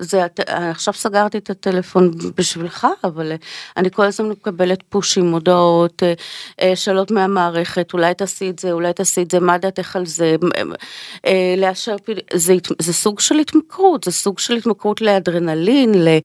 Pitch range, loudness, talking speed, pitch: 175-200 Hz, -17 LUFS, 145 wpm, 185 Hz